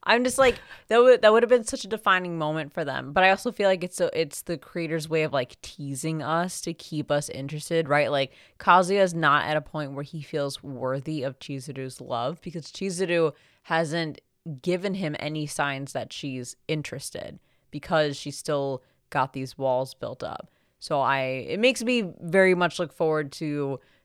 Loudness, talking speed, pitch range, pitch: -25 LUFS, 190 wpm, 140-180 Hz, 155 Hz